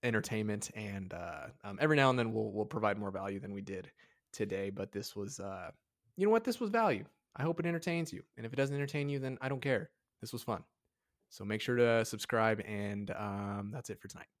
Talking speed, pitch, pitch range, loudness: 235 wpm, 110 Hz, 100-140 Hz, -36 LUFS